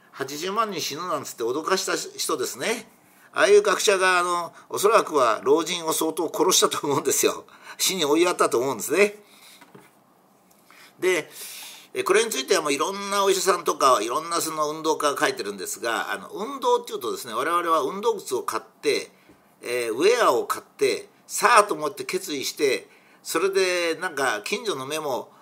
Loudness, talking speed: -23 LUFS, 355 characters per minute